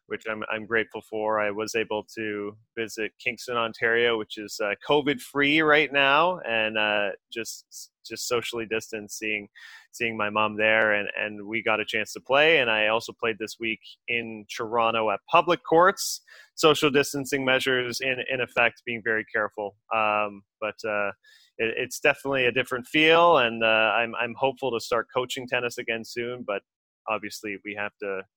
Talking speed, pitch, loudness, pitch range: 175 wpm, 115 Hz, -25 LUFS, 105-125 Hz